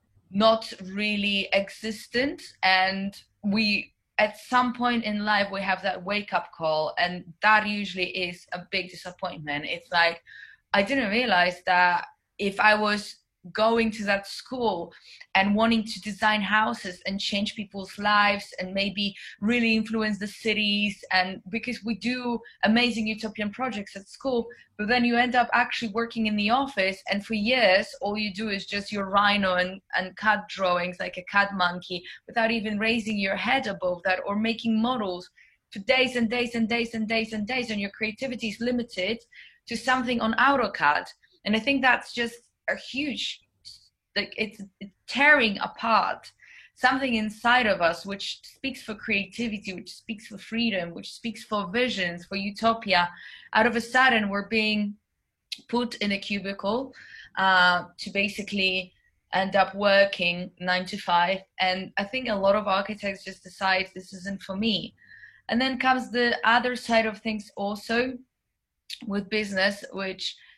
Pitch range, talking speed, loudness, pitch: 190-230 Hz, 160 wpm, -25 LUFS, 210 Hz